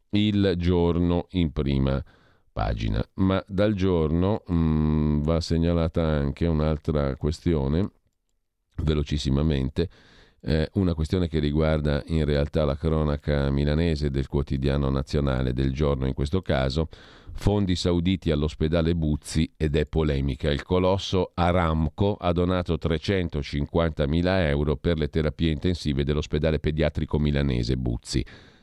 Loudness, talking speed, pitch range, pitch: -25 LUFS, 115 wpm, 75-85 Hz, 80 Hz